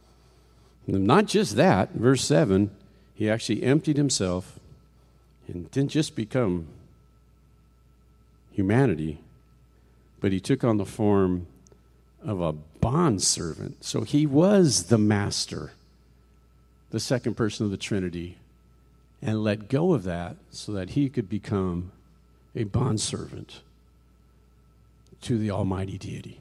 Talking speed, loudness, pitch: 120 wpm, -25 LUFS, 95 Hz